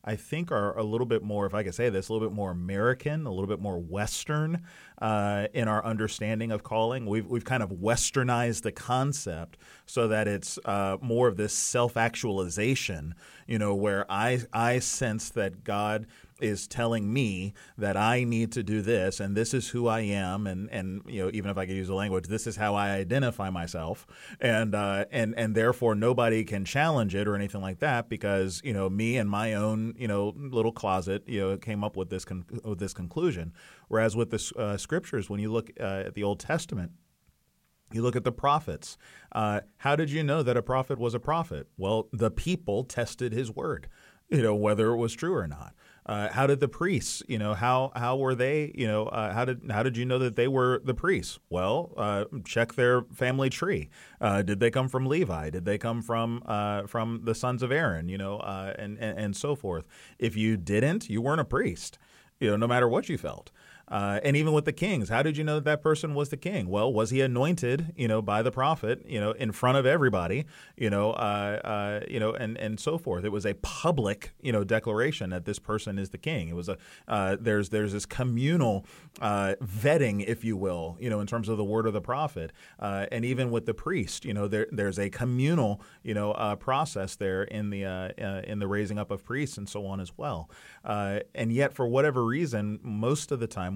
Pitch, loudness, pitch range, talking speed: 110 Hz, -29 LUFS, 100-125 Hz, 225 wpm